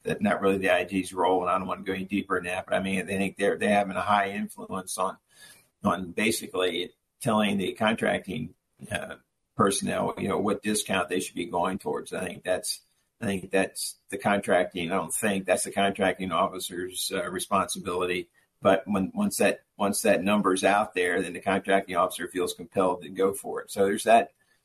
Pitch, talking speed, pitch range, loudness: 95 Hz, 200 wpm, 95-100 Hz, -27 LUFS